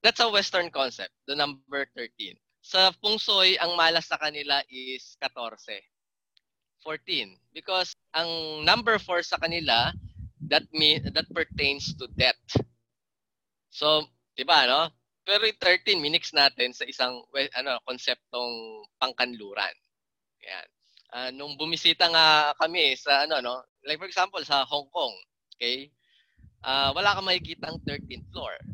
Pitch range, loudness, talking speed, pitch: 130-170 Hz, -25 LUFS, 135 wpm, 145 Hz